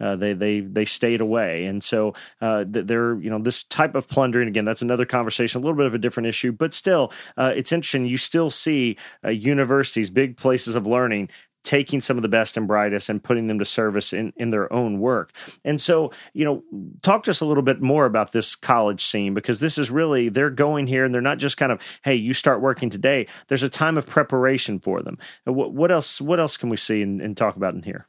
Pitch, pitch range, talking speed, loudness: 125 Hz, 110-140 Hz, 240 wpm, -21 LUFS